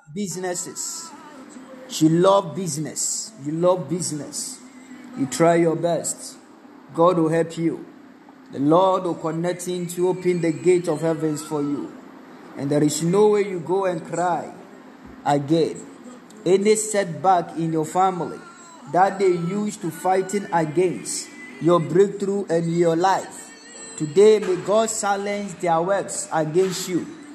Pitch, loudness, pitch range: 185 Hz, -22 LUFS, 165-220 Hz